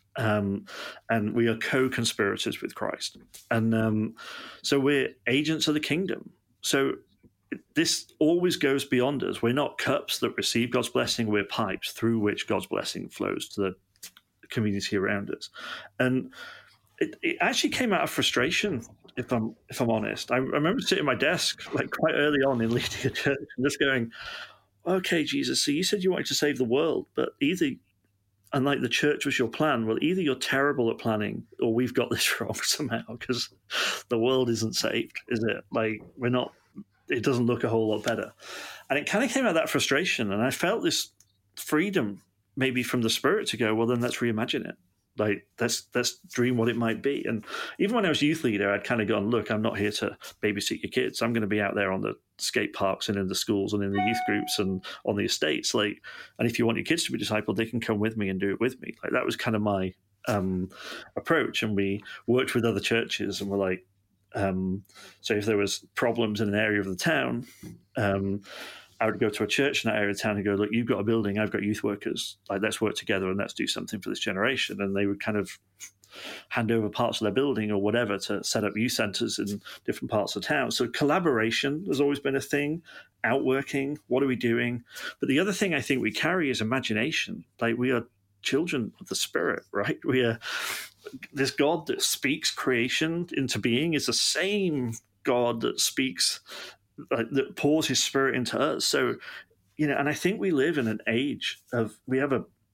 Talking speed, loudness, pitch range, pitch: 215 wpm, -27 LUFS, 105-130 Hz, 115 Hz